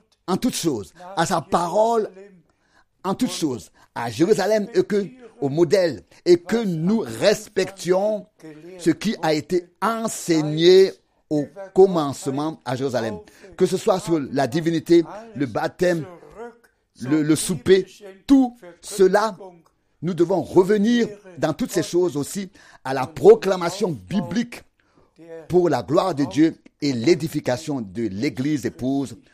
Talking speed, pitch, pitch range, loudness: 130 wpm, 180 Hz, 155-200 Hz, -21 LUFS